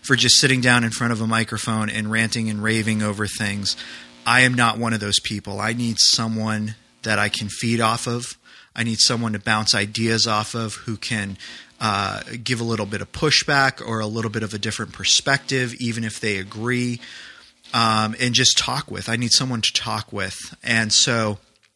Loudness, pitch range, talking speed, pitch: -20 LUFS, 105-120 Hz, 200 wpm, 110 Hz